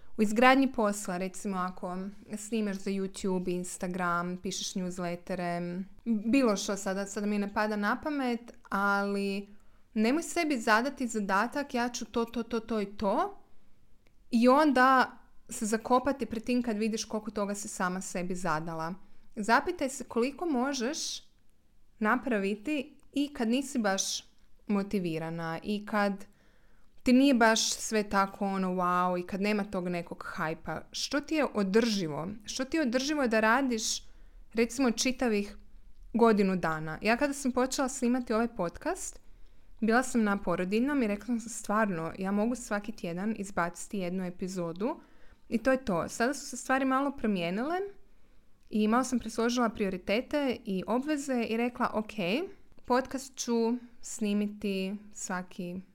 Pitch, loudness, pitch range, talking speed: 220 Hz, -30 LUFS, 195-250 Hz, 140 wpm